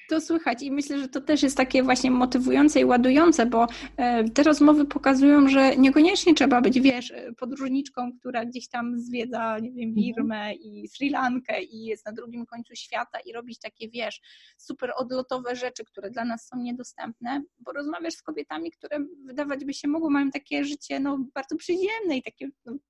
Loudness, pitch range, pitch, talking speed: -24 LUFS, 235-285 Hz, 260 Hz, 180 wpm